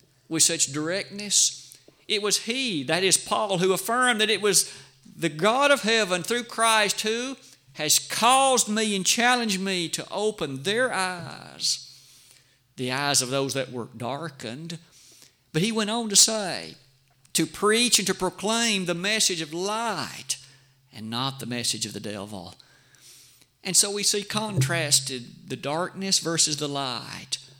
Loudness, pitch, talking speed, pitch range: -23 LUFS, 165 Hz, 150 wpm, 135-210 Hz